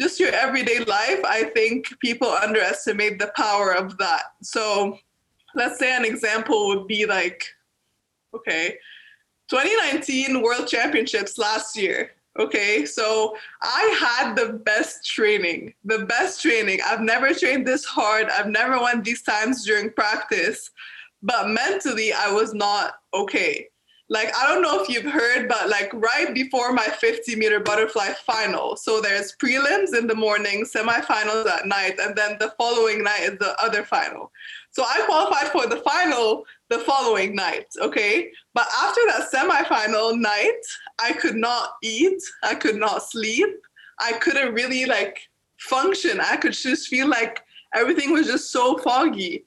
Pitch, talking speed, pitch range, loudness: 240 Hz, 155 wpm, 215-340 Hz, -21 LUFS